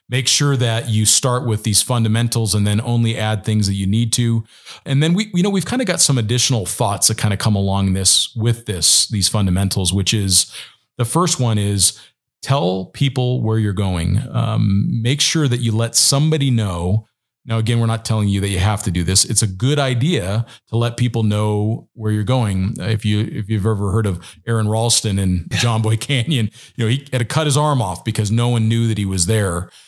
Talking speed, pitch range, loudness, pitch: 225 wpm, 105-125 Hz, -17 LUFS, 110 Hz